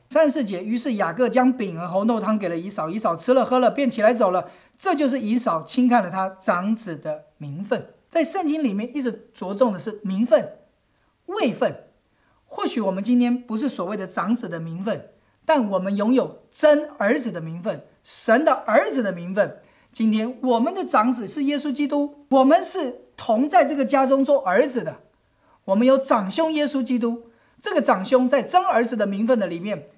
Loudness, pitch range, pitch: -22 LUFS, 205-280 Hz, 240 Hz